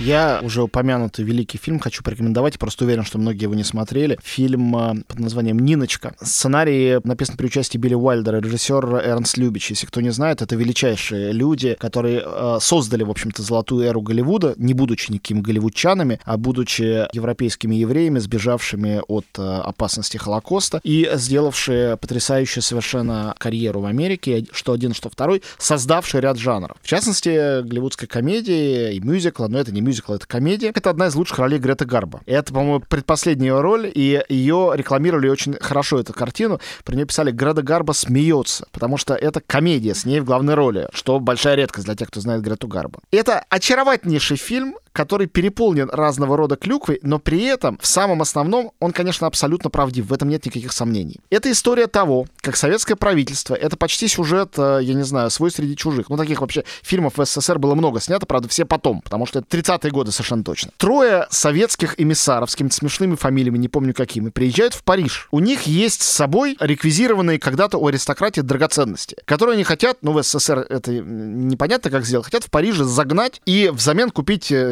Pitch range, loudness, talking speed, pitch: 120-160 Hz, -19 LUFS, 175 wpm, 135 Hz